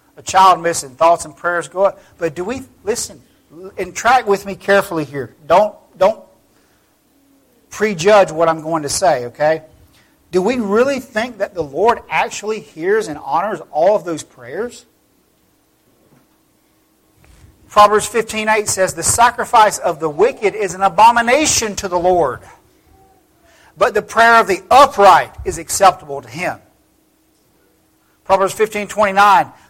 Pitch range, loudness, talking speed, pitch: 170-235 Hz, -15 LUFS, 135 wpm, 200 Hz